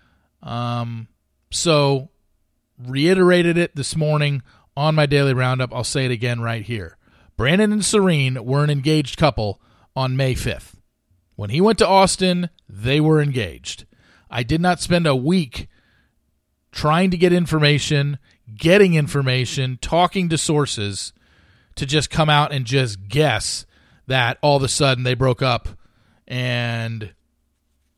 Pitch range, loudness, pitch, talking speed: 115-155 Hz, -19 LUFS, 135 Hz, 140 wpm